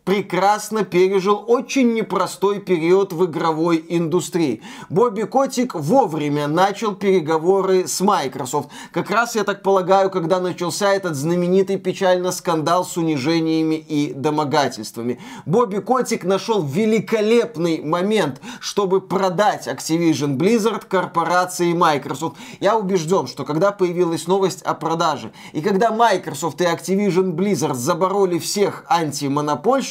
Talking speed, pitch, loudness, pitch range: 115 wpm, 185 Hz, -19 LUFS, 165-200 Hz